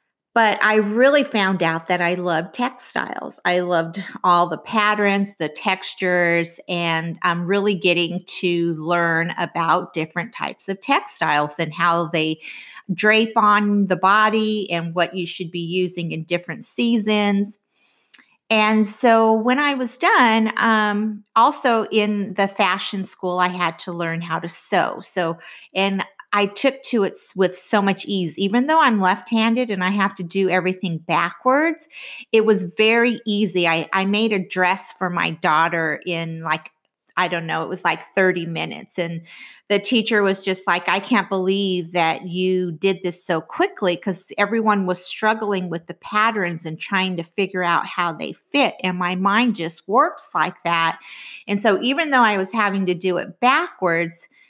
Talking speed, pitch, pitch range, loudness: 170 wpm, 190 Hz, 175-215 Hz, -20 LUFS